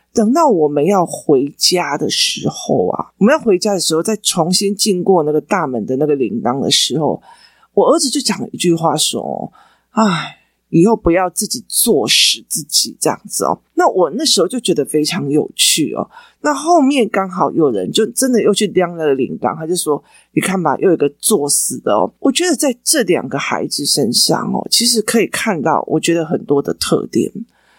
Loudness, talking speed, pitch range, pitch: -14 LUFS, 280 characters per minute, 165-235 Hz, 195 Hz